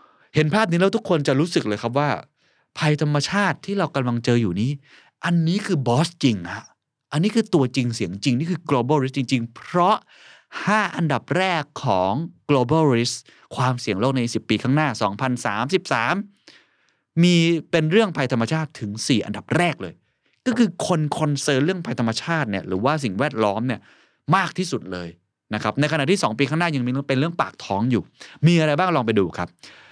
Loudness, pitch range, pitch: -22 LUFS, 120-170 Hz, 145 Hz